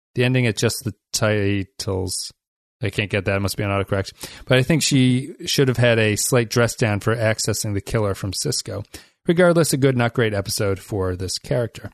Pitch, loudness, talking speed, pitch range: 110 Hz, -20 LUFS, 205 wpm, 100-125 Hz